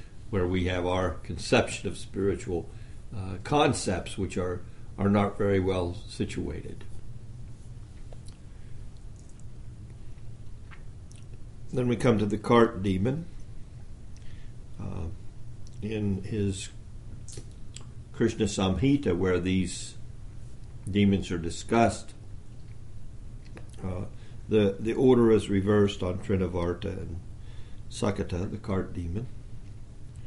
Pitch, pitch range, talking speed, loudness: 110 Hz, 100-115 Hz, 90 wpm, -28 LUFS